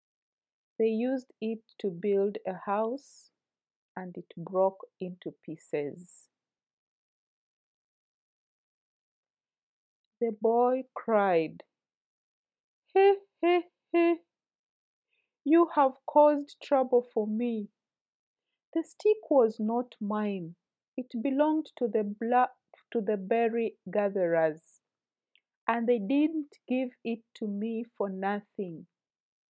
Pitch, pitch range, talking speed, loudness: 230 Hz, 205-270 Hz, 95 wpm, -29 LUFS